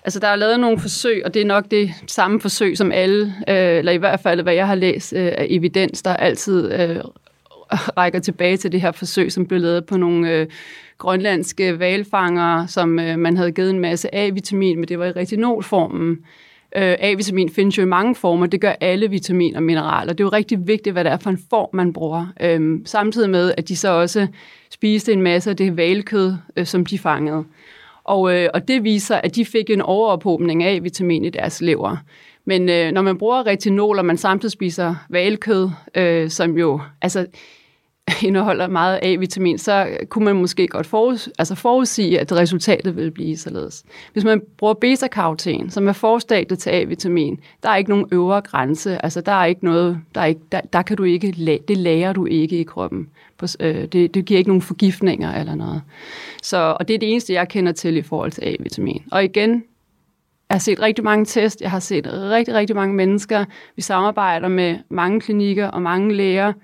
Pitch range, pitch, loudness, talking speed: 175-205 Hz, 185 Hz, -18 LUFS, 195 wpm